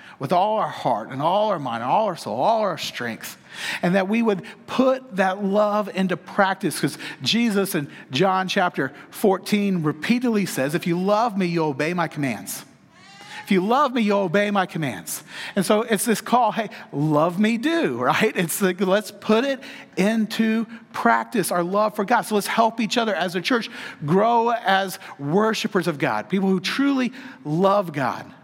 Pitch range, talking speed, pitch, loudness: 180-225 Hz, 185 wpm, 200 Hz, -22 LUFS